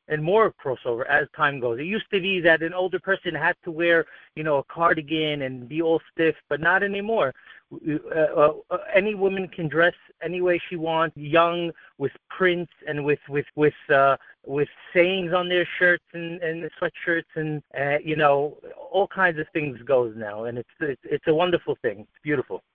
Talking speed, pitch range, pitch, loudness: 195 wpm, 150-185 Hz, 165 Hz, -24 LUFS